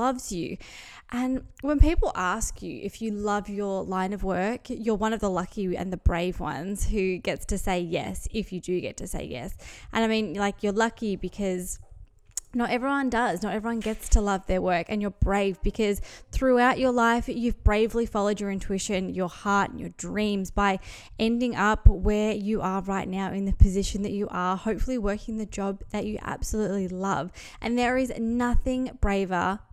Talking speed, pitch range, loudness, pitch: 195 wpm, 190-225 Hz, -27 LUFS, 205 Hz